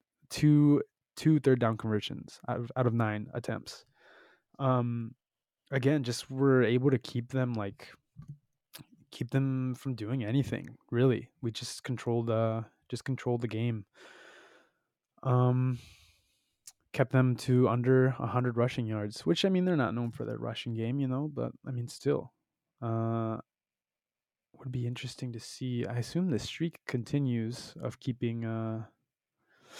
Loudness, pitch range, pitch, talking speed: -31 LUFS, 115-135 Hz, 125 Hz, 145 wpm